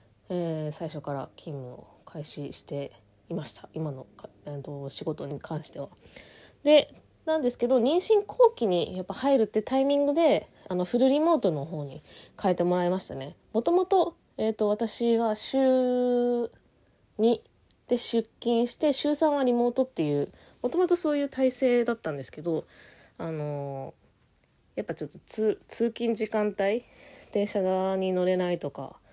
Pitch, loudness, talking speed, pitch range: 220 Hz, -27 LUFS, 275 characters per minute, 160-260 Hz